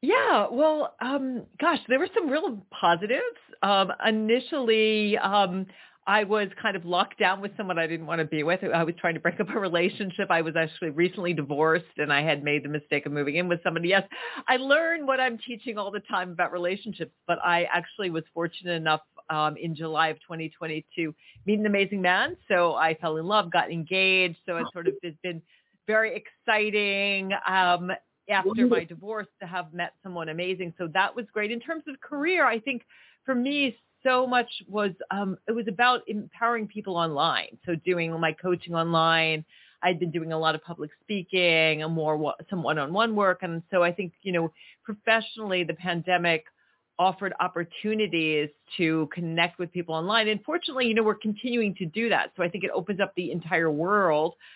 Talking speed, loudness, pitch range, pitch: 190 wpm, -26 LUFS, 165-215 Hz, 185 Hz